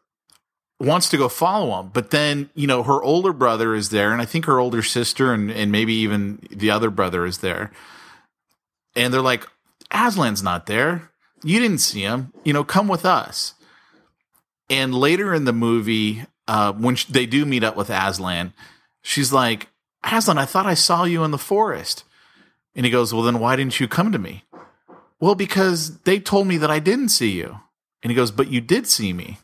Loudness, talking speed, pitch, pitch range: -20 LUFS, 200 wpm, 125 Hz, 110-160 Hz